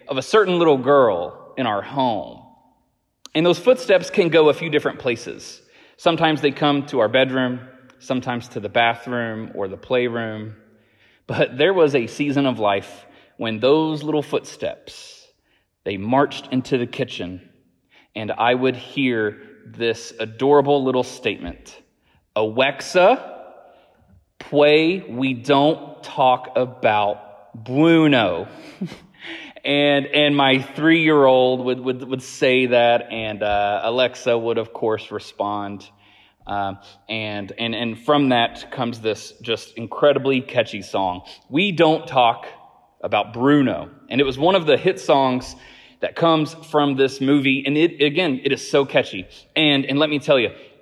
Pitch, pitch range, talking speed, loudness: 130 Hz, 115-145 Hz, 145 wpm, -19 LUFS